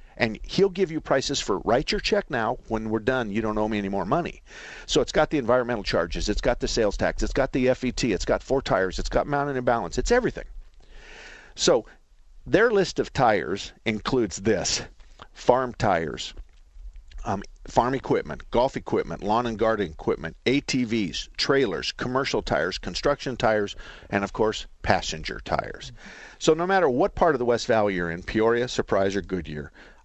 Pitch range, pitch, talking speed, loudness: 100-135 Hz, 115 Hz, 180 wpm, -25 LUFS